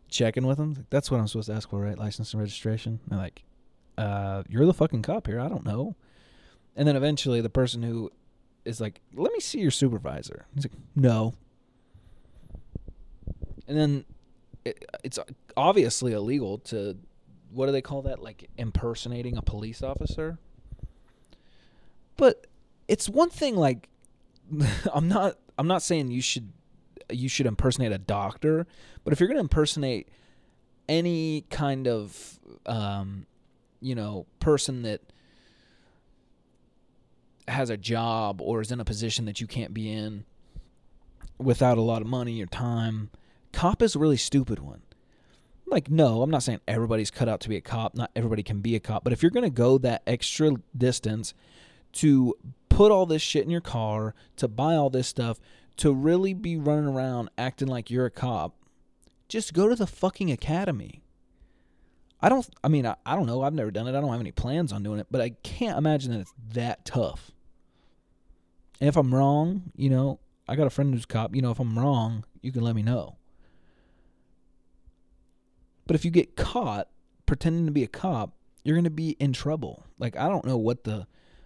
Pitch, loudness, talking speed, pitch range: 120 Hz, -27 LUFS, 180 wpm, 110-145 Hz